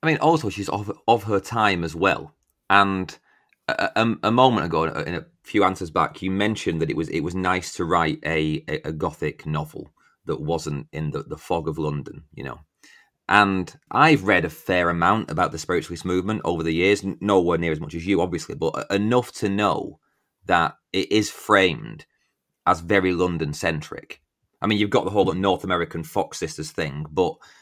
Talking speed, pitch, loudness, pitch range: 200 wpm, 95 Hz, -22 LUFS, 80-105 Hz